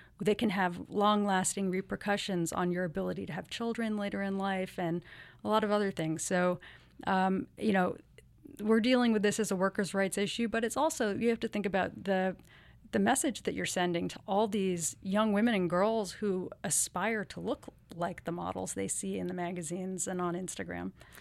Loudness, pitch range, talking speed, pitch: -32 LUFS, 180-210 Hz, 195 wpm, 195 Hz